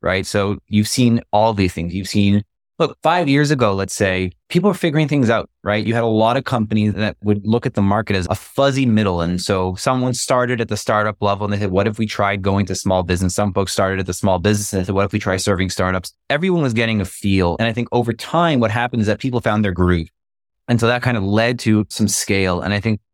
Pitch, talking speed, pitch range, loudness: 105 Hz, 265 wpm, 95-115 Hz, -18 LUFS